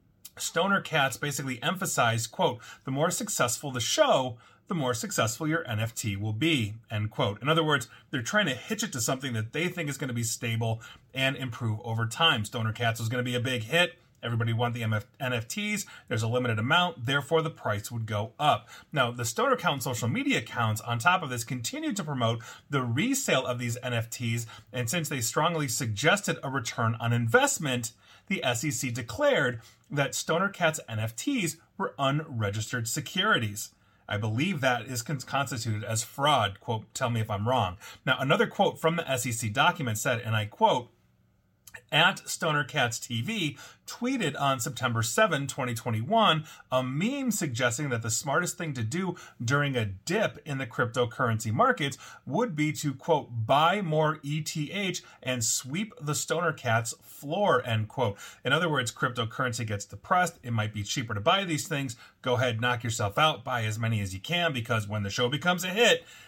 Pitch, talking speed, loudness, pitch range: 125 Hz, 180 wpm, -28 LUFS, 115-155 Hz